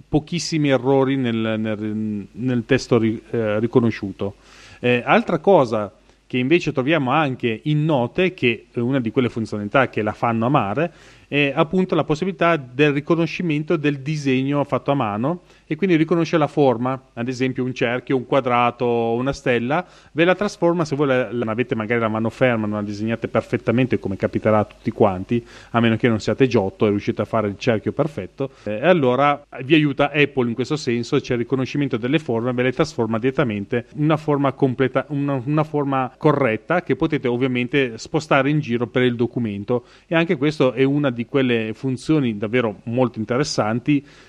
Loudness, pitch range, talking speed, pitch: -20 LUFS, 115-145 Hz, 175 wpm, 130 Hz